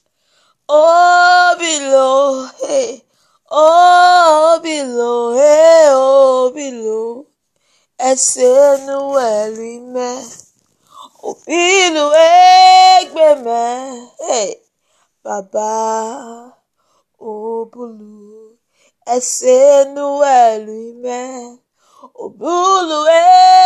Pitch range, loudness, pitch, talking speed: 240-330 Hz, -11 LUFS, 275 Hz, 55 wpm